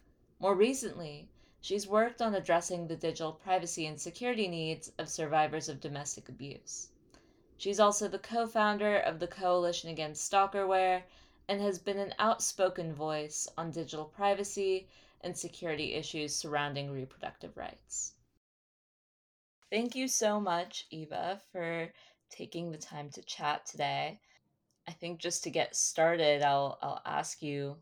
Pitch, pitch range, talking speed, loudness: 170 Hz, 155-195 Hz, 140 wpm, -33 LUFS